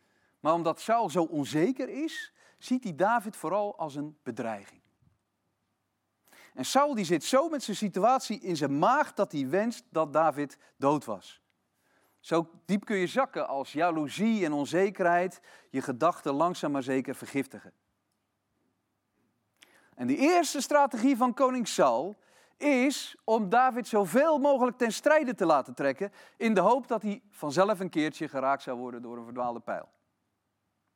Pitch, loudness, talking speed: 175 Hz, -28 LUFS, 150 wpm